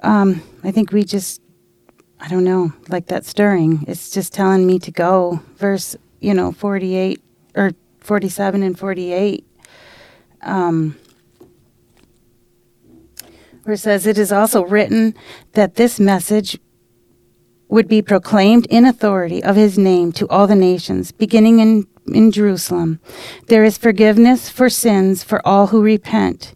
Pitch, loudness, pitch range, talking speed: 200 Hz, -15 LUFS, 185-215 Hz, 135 wpm